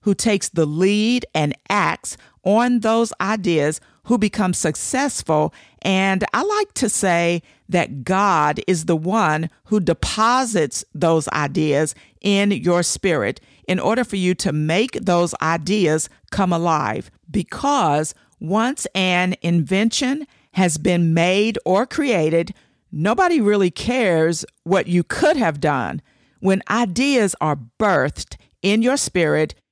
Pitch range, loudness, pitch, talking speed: 165-220 Hz, -19 LUFS, 185 Hz, 125 wpm